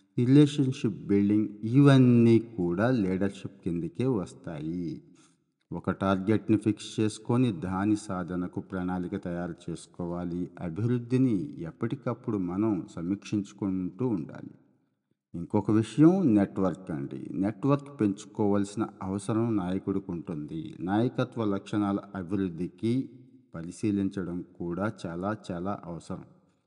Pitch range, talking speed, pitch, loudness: 95-120 Hz, 85 wpm, 105 Hz, -28 LUFS